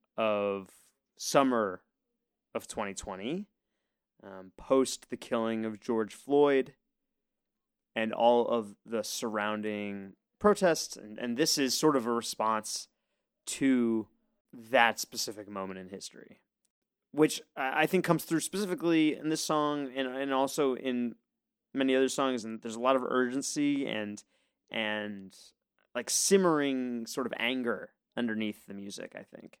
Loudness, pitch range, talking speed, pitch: -30 LUFS, 110-150 Hz, 130 wpm, 125 Hz